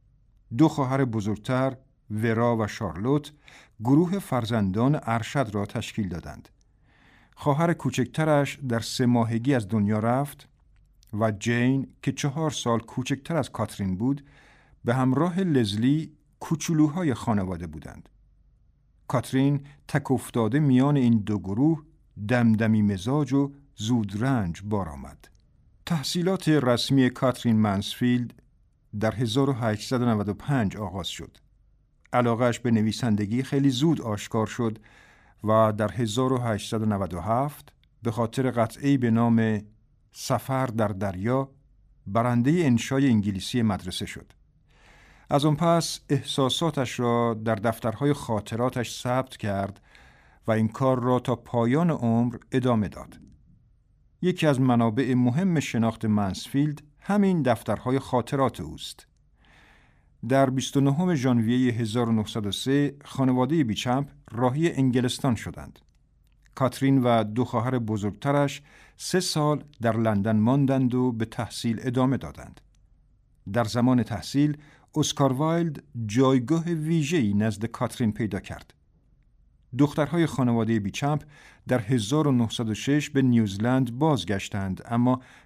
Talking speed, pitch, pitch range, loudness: 105 wpm, 125 Hz, 110-140 Hz, -25 LUFS